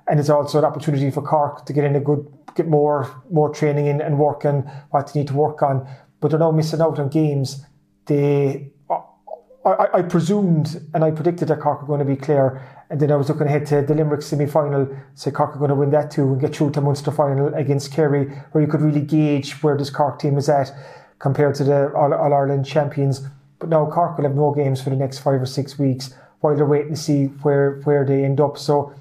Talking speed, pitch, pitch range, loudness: 240 wpm, 145 Hz, 140-150 Hz, -19 LUFS